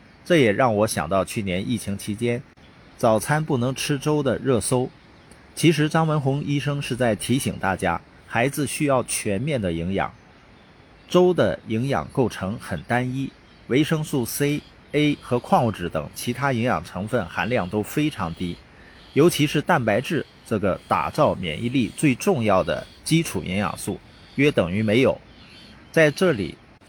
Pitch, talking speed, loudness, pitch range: 125 Hz, 230 characters per minute, -23 LUFS, 100-145 Hz